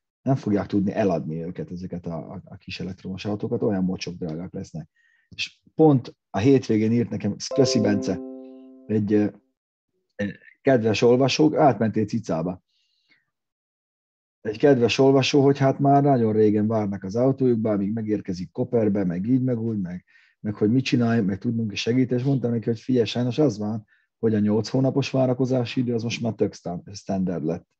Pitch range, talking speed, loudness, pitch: 105-130 Hz, 165 wpm, -23 LUFS, 115 Hz